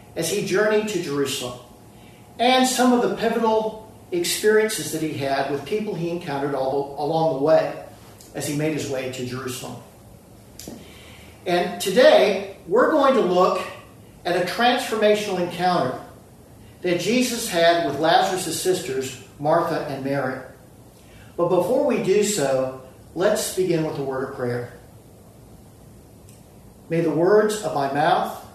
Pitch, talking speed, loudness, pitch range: 155 Hz, 140 wpm, -21 LUFS, 130-190 Hz